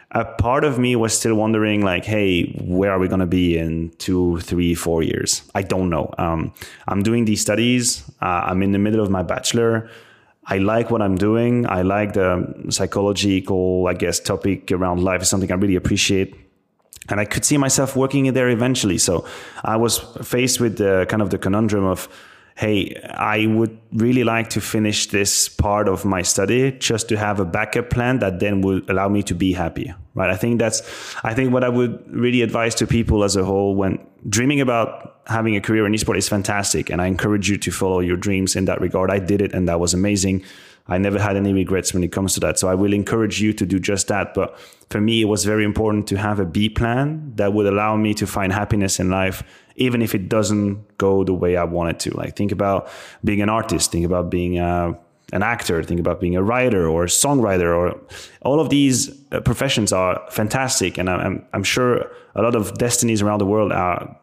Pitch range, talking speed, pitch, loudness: 95-115 Hz, 220 wpm, 100 Hz, -19 LUFS